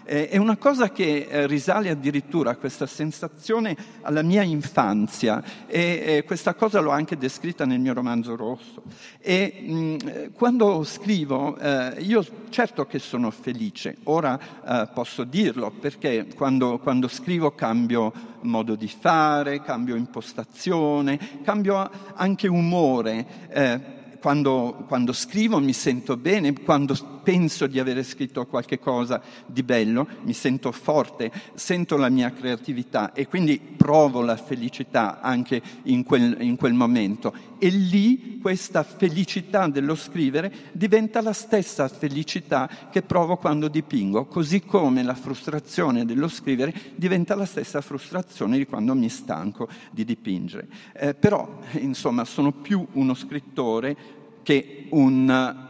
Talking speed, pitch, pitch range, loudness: 135 wpm, 155 Hz, 135-200 Hz, -24 LUFS